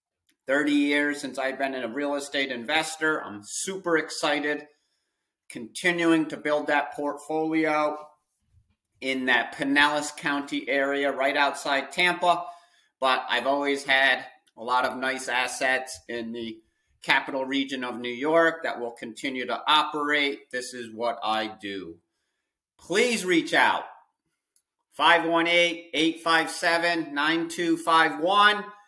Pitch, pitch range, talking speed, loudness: 145 Hz, 130-160 Hz, 120 wpm, -25 LUFS